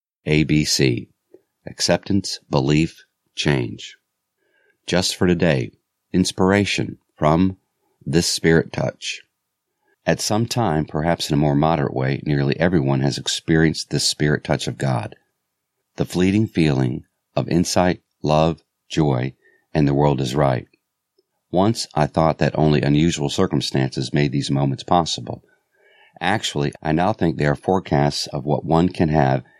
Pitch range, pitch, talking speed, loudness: 70-85 Hz, 75 Hz, 135 wpm, -20 LUFS